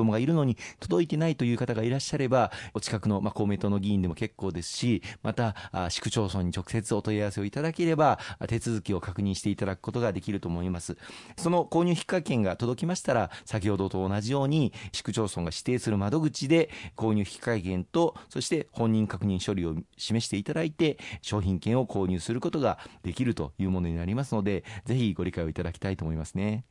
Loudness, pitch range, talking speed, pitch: -29 LUFS, 95-125 Hz, 425 characters per minute, 110 Hz